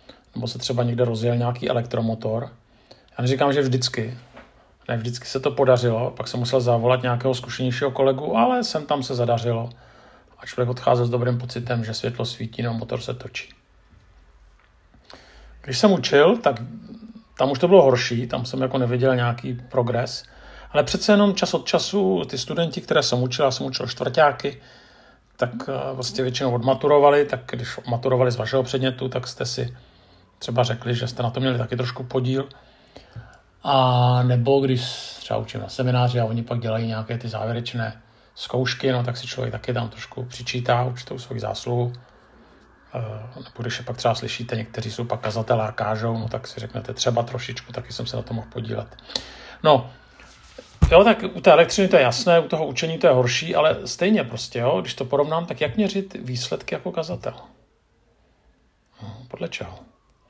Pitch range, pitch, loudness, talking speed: 120-130 Hz, 125 Hz, -22 LUFS, 175 wpm